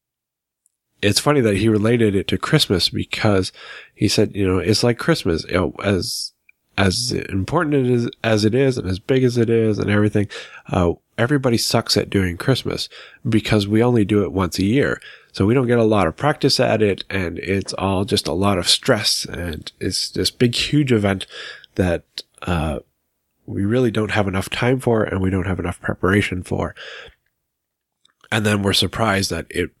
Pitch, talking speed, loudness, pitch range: 105 Hz, 190 wpm, -19 LUFS, 95-120 Hz